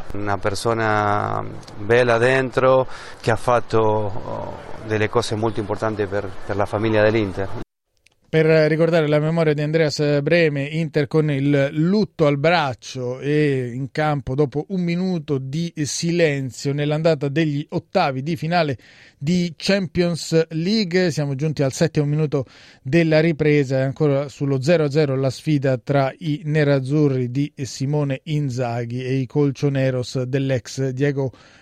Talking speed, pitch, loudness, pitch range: 130 wpm, 140 Hz, -20 LUFS, 125-155 Hz